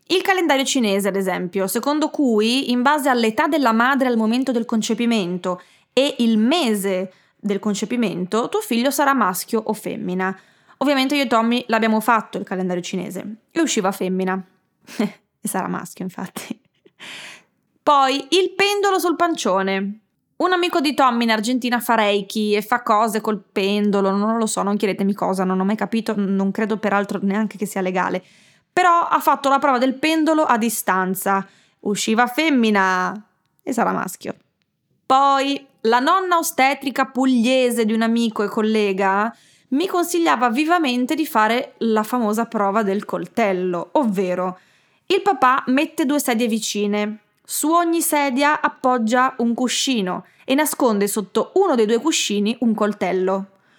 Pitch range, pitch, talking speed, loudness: 200-275 Hz, 225 Hz, 150 wpm, -19 LUFS